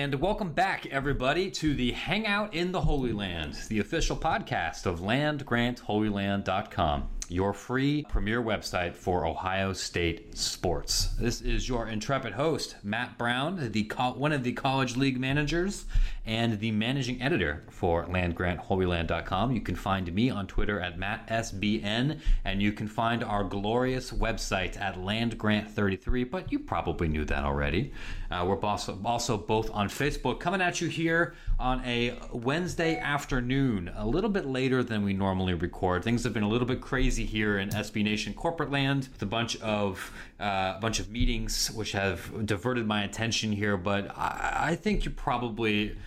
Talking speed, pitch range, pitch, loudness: 165 wpm, 100-130 Hz, 110 Hz, -30 LUFS